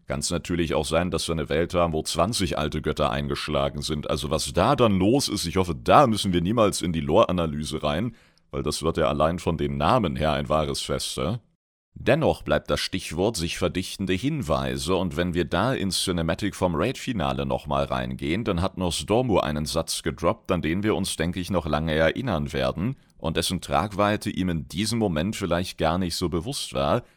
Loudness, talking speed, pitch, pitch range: -25 LUFS, 200 wpm, 85 Hz, 75-95 Hz